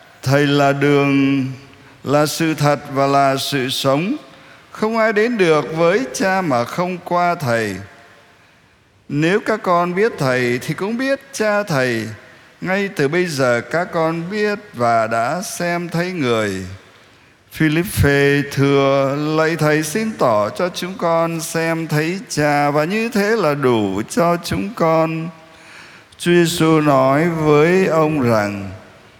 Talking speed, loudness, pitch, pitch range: 140 wpm, -17 LUFS, 155 Hz, 135-175 Hz